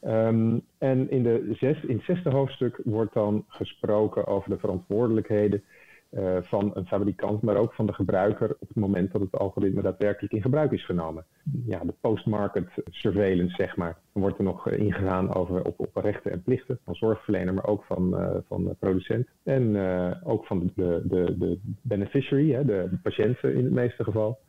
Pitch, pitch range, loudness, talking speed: 105 Hz, 95-115 Hz, -27 LUFS, 185 wpm